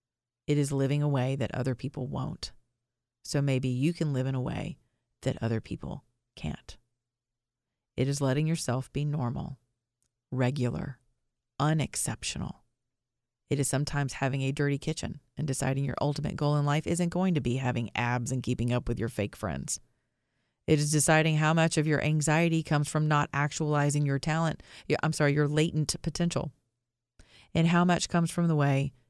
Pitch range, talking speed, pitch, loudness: 120-150 Hz, 170 wpm, 135 Hz, -29 LUFS